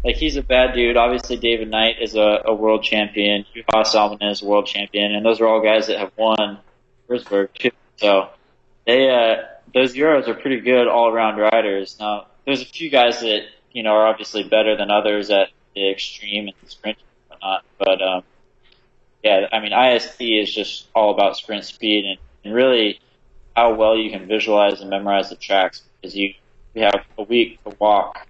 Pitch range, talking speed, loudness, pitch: 105-115 Hz, 195 wpm, -18 LUFS, 110 Hz